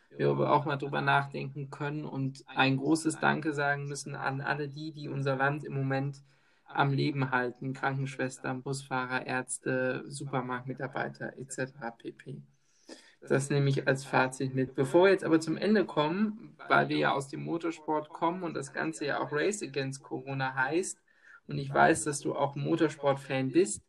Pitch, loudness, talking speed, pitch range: 140 Hz, -31 LUFS, 165 wpm, 130-150 Hz